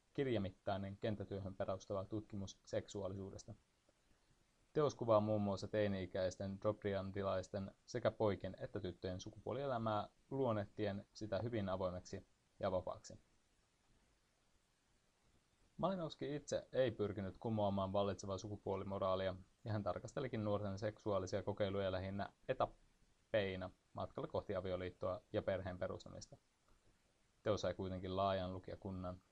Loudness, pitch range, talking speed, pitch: -43 LUFS, 95-105 Hz, 95 wpm, 100 Hz